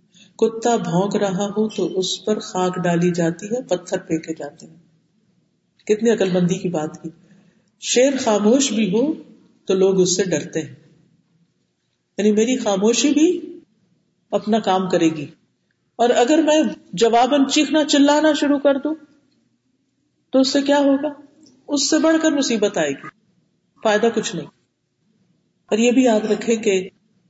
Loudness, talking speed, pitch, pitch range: -18 LUFS, 150 wpm, 210 Hz, 180-260 Hz